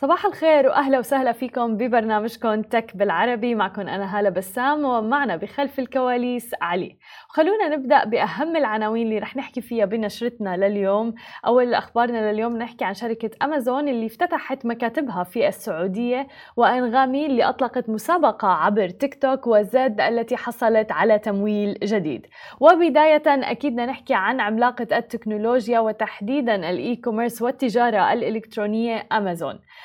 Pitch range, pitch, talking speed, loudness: 215-270 Hz, 235 Hz, 125 wpm, -21 LUFS